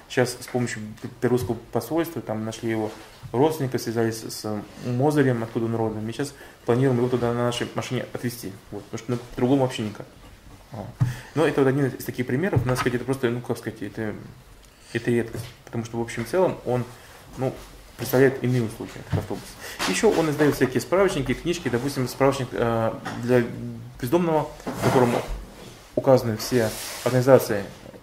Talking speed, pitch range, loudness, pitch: 155 wpm, 115-130 Hz, -24 LUFS, 120 Hz